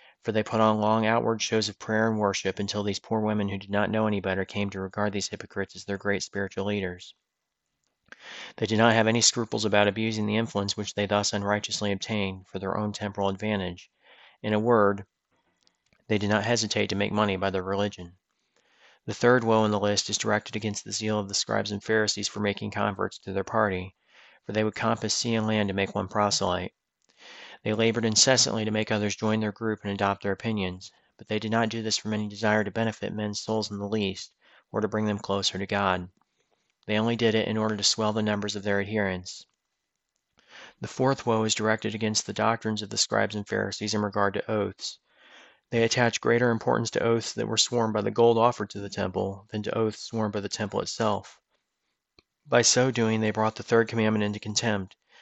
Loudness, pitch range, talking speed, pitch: -26 LUFS, 100-110 Hz, 215 wpm, 105 Hz